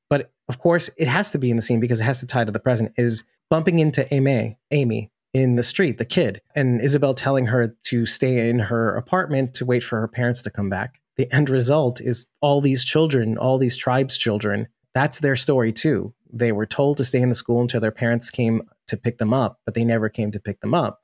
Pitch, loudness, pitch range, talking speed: 125 Hz, -20 LUFS, 115-135 Hz, 240 wpm